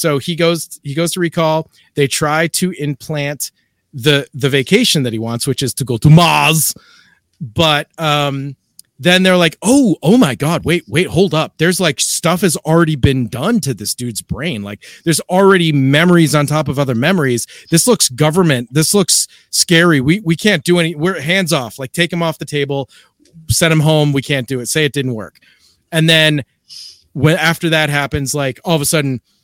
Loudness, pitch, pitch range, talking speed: -13 LUFS, 155 Hz, 140-170 Hz, 200 wpm